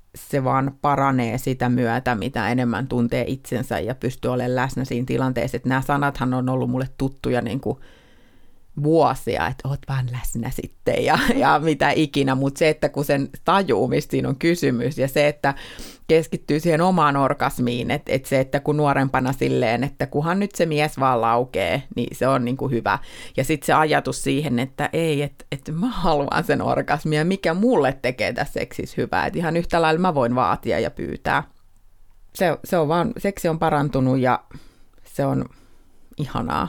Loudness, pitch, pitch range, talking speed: -21 LUFS, 135 Hz, 125-150 Hz, 175 wpm